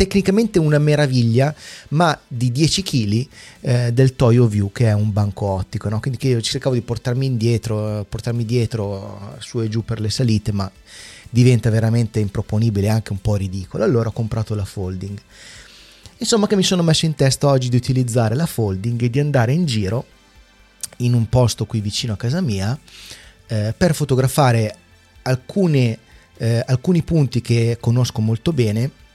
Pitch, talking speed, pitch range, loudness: 115 Hz, 165 wpm, 105-130 Hz, -19 LUFS